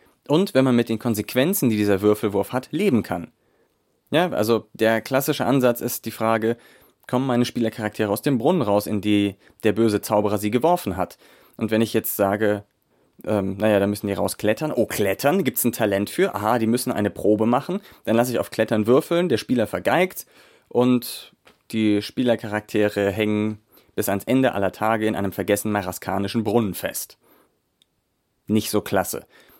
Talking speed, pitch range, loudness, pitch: 175 wpm, 105-120 Hz, -22 LUFS, 110 Hz